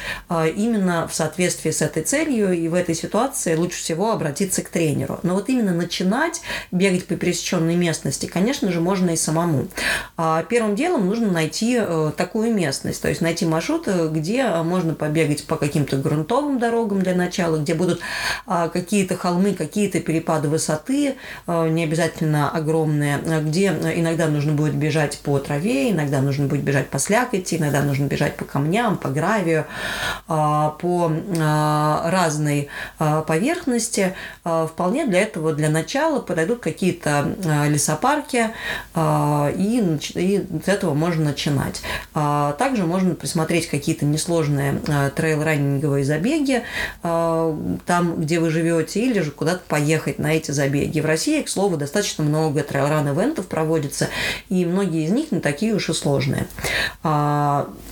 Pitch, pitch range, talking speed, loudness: 165 Hz, 155-190 Hz, 135 wpm, -21 LUFS